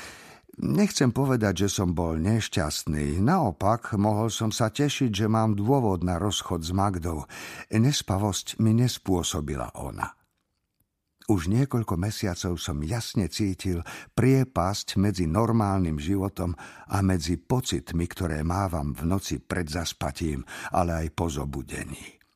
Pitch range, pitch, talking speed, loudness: 85-110 Hz, 95 Hz, 120 wpm, -27 LUFS